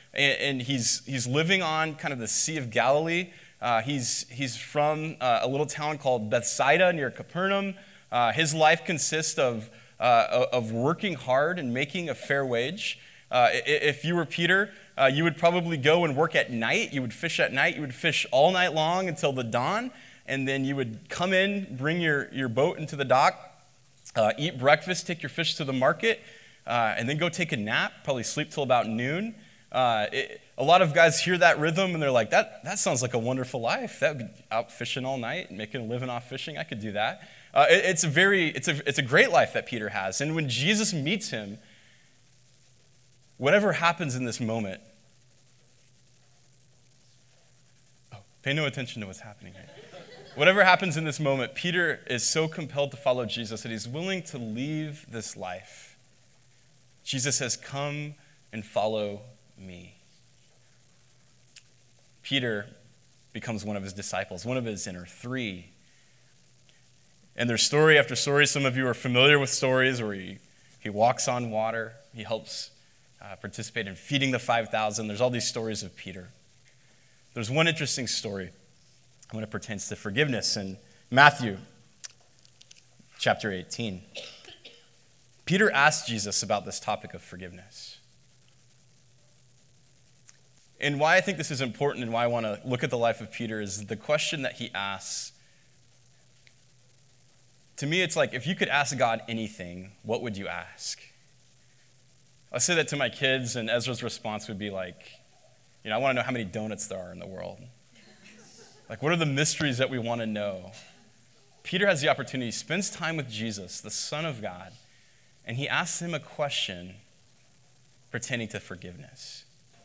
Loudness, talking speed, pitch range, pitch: -26 LUFS, 175 wpm, 115-150 Hz, 130 Hz